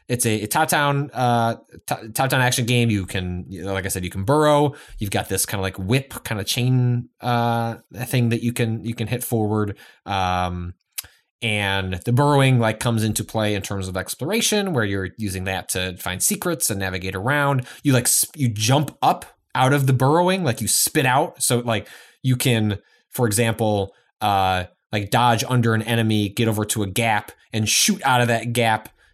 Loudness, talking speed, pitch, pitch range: -21 LUFS, 195 wpm, 115 Hz, 100-125 Hz